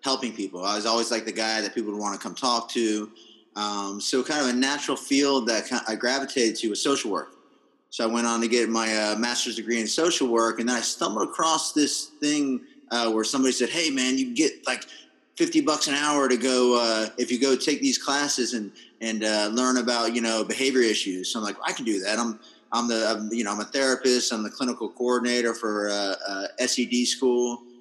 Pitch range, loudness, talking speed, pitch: 110-135 Hz, -25 LUFS, 235 wpm, 120 Hz